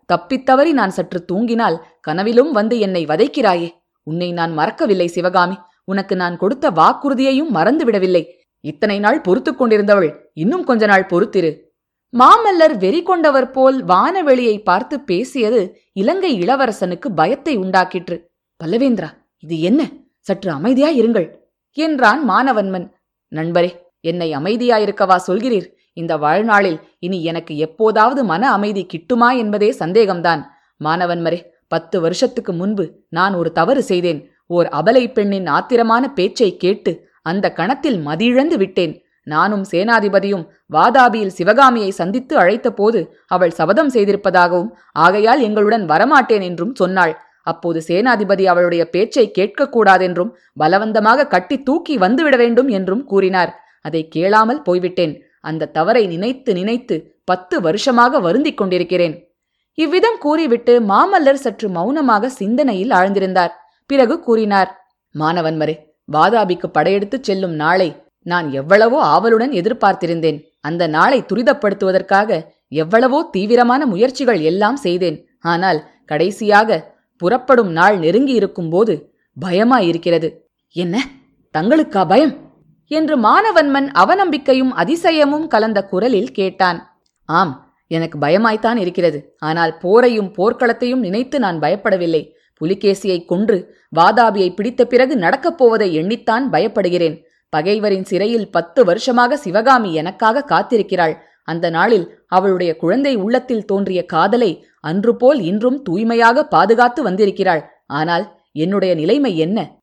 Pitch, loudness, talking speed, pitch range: 200 Hz, -15 LUFS, 110 wpm, 175-245 Hz